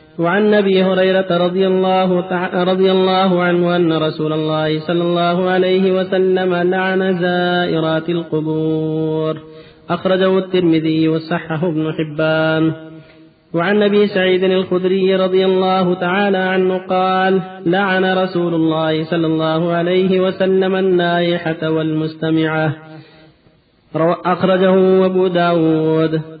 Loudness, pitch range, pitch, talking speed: -15 LUFS, 160-185 Hz, 175 Hz, 100 wpm